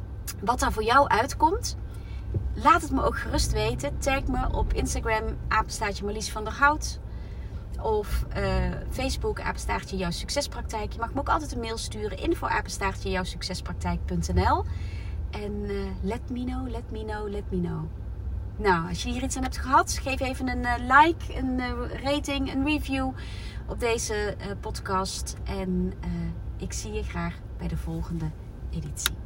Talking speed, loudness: 165 wpm, -28 LUFS